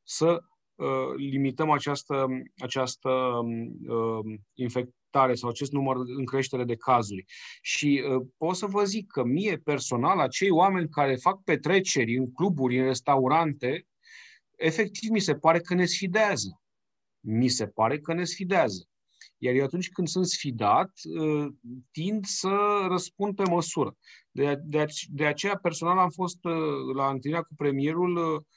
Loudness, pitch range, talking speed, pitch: -27 LUFS, 130-180 Hz, 145 wpm, 150 Hz